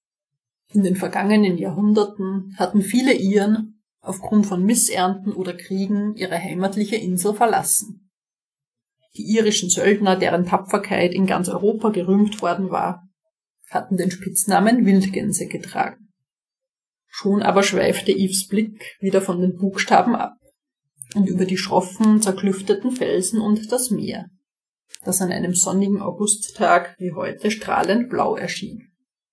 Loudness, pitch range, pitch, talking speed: -19 LUFS, 185-210 Hz, 195 Hz, 125 wpm